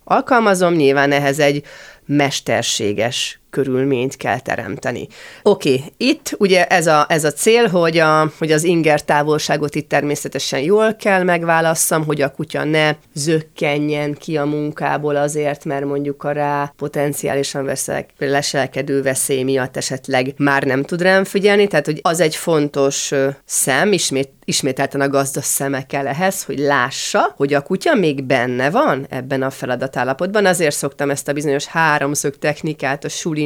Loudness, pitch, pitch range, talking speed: -17 LUFS, 145 Hz, 140-160 Hz, 150 wpm